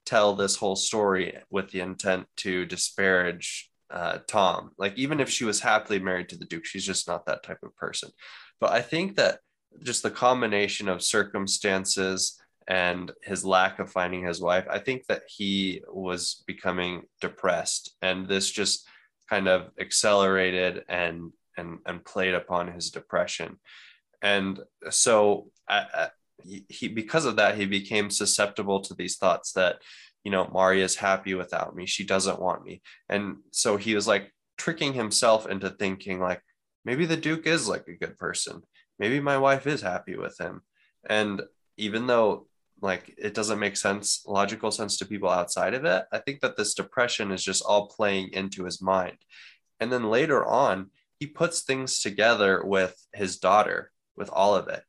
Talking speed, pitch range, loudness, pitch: 175 wpm, 95-110 Hz, -26 LUFS, 100 Hz